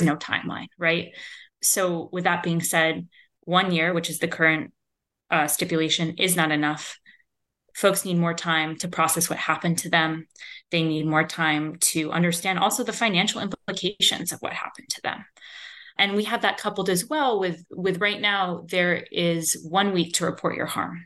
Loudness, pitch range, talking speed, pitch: -23 LUFS, 160-195 Hz, 180 wpm, 175 Hz